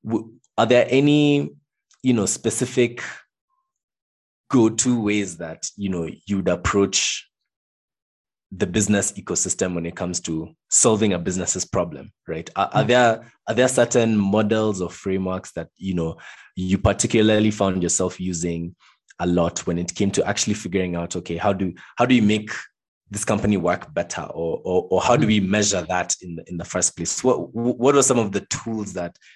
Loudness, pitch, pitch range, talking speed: -21 LUFS, 100 Hz, 90-115 Hz, 170 wpm